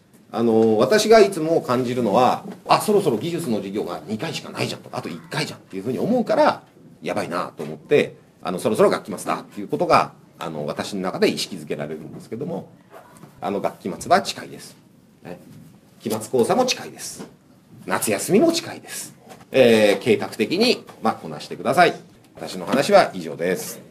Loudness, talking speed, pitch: -21 LUFS, 365 characters per minute, 165 Hz